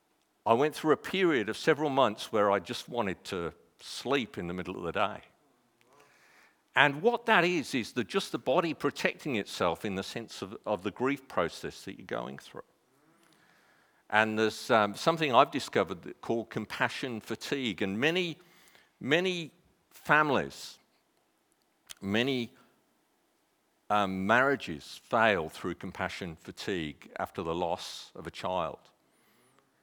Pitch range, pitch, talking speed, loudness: 105-155 Hz, 125 Hz, 140 wpm, -30 LUFS